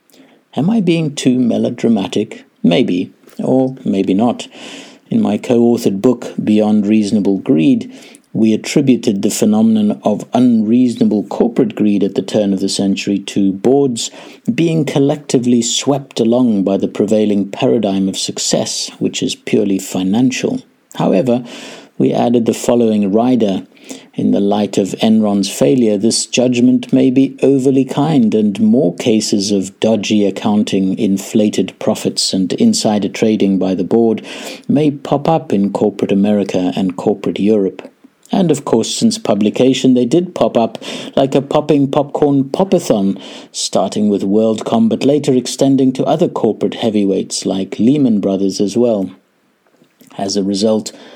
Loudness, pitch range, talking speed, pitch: -14 LUFS, 100-145 Hz, 140 wpm, 120 Hz